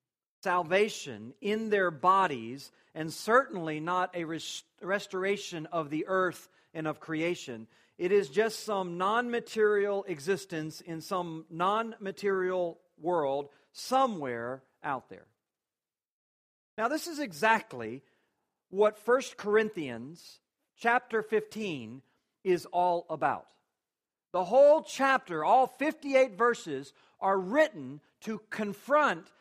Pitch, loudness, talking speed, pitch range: 185 Hz, -30 LUFS, 105 wpm, 160-220 Hz